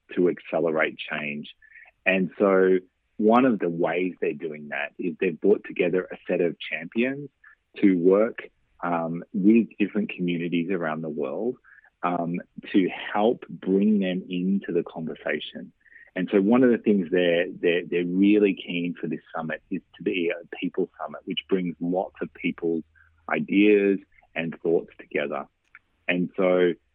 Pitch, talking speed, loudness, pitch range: 90 Hz, 150 wpm, -25 LUFS, 85-100 Hz